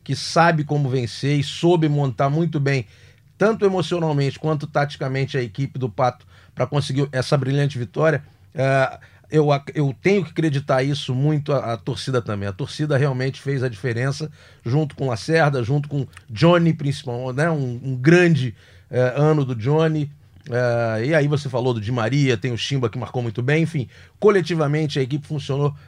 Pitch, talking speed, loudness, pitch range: 140 Hz, 175 wpm, -21 LUFS, 125-150 Hz